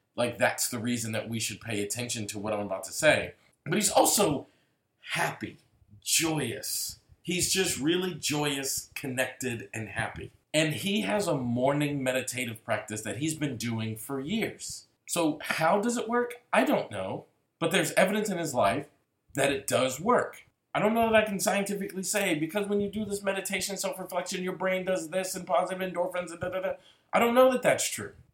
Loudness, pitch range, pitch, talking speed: -29 LUFS, 120-195 Hz, 160 Hz, 190 wpm